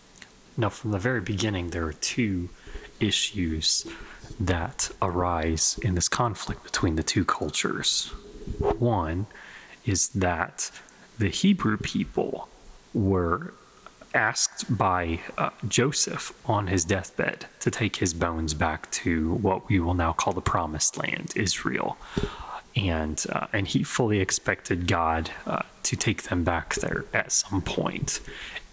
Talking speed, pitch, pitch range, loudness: 130 wpm, 90 Hz, 85-100 Hz, -26 LUFS